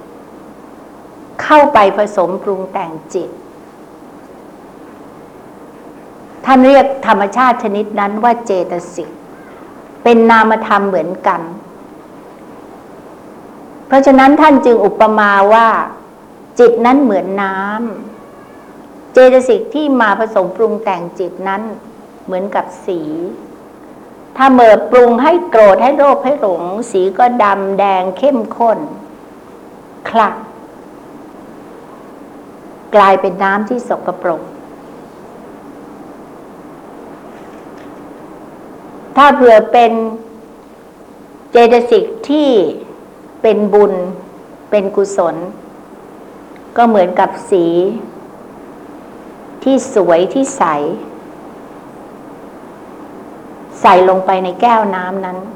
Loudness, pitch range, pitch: -11 LUFS, 195-255 Hz, 220 Hz